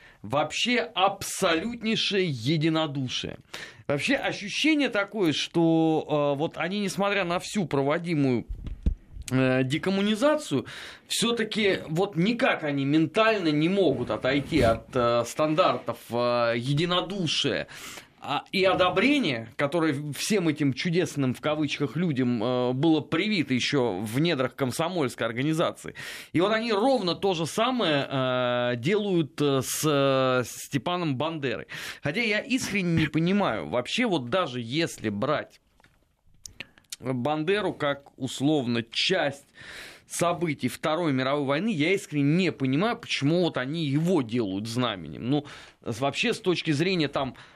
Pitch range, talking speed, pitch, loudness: 130-185 Hz, 110 wpm, 155 Hz, -26 LUFS